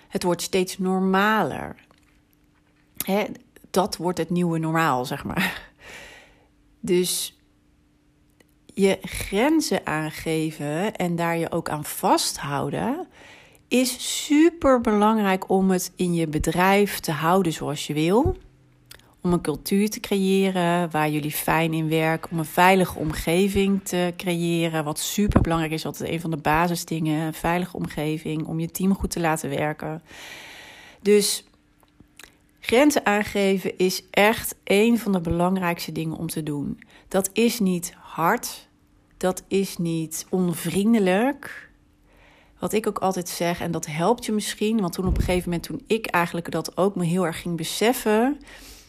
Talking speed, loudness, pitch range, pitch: 140 wpm, -23 LUFS, 165-200 Hz, 180 Hz